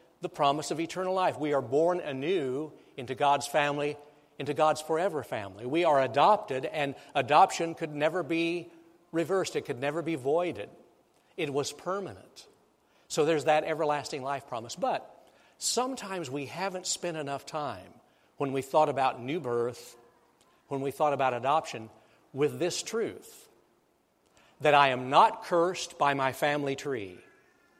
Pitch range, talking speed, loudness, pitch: 140-170 Hz, 150 wpm, -29 LUFS, 150 Hz